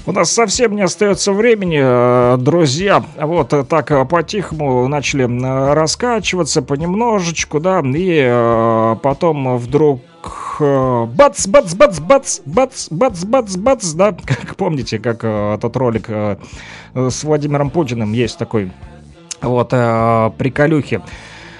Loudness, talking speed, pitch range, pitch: -14 LUFS, 85 wpm, 125-180 Hz, 145 Hz